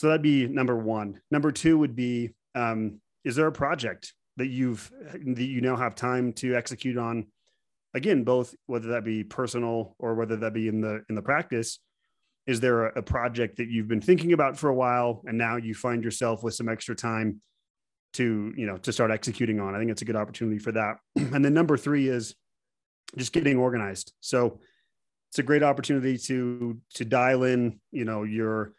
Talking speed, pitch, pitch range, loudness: 200 wpm, 120 Hz, 110-130 Hz, -27 LUFS